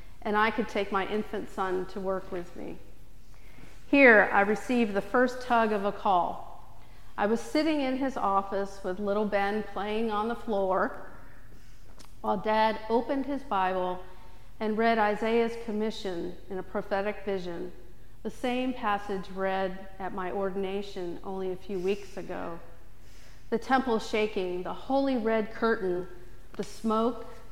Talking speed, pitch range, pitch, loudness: 145 wpm, 185-225 Hz, 200 Hz, -29 LUFS